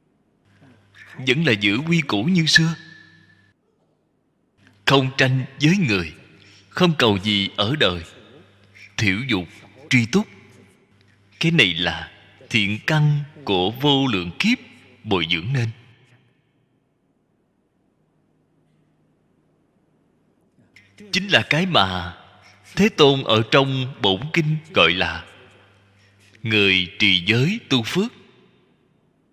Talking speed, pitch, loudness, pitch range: 100 wpm, 120 Hz, -19 LUFS, 100-150 Hz